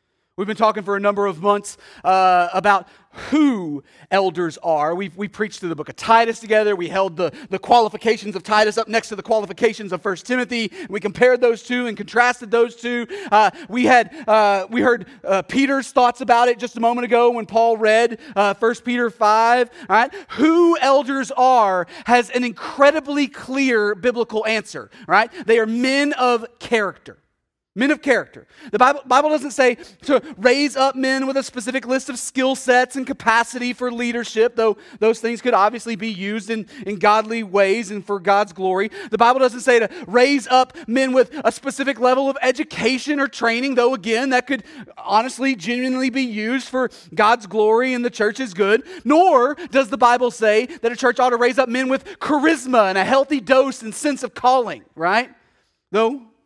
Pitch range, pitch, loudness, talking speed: 215-260 Hz, 235 Hz, -18 LUFS, 190 wpm